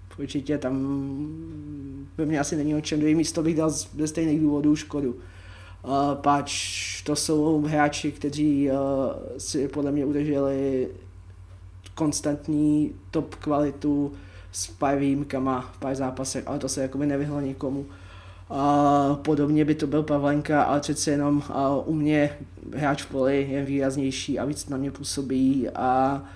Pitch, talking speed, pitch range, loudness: 140 Hz, 150 wpm, 135-150 Hz, -25 LUFS